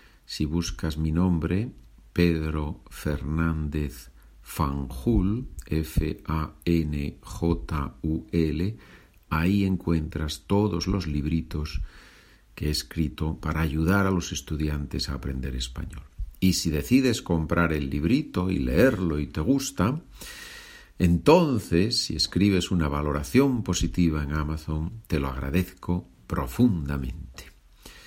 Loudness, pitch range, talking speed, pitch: -26 LUFS, 75-90 Hz, 100 wpm, 80 Hz